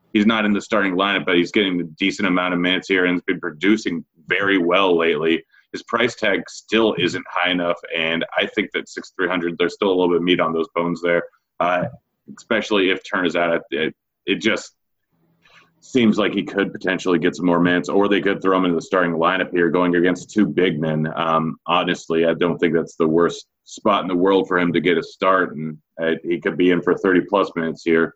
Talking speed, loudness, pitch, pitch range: 230 wpm, -19 LUFS, 85 Hz, 85-90 Hz